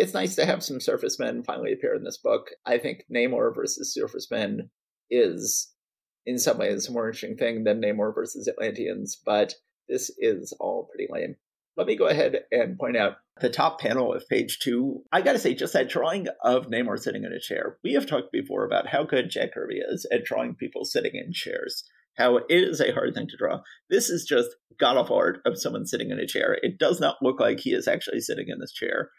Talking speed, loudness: 225 wpm, -26 LUFS